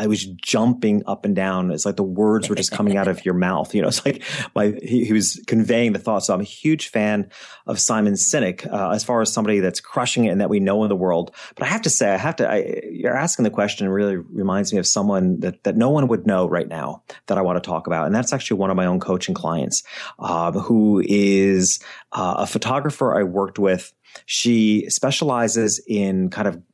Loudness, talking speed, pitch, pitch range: -20 LUFS, 240 wpm, 100 Hz, 95-110 Hz